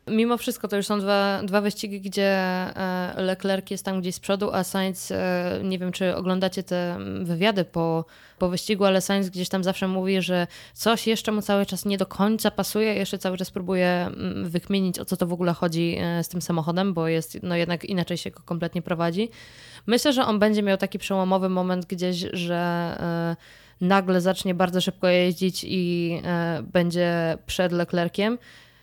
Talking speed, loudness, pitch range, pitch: 175 wpm, -25 LUFS, 175-195 Hz, 185 Hz